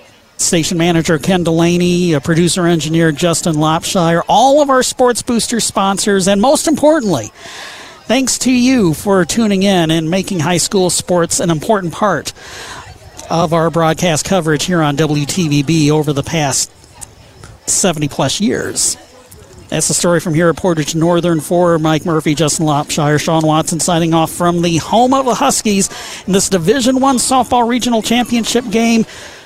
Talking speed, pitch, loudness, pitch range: 155 wpm, 175 Hz, -13 LUFS, 160-210 Hz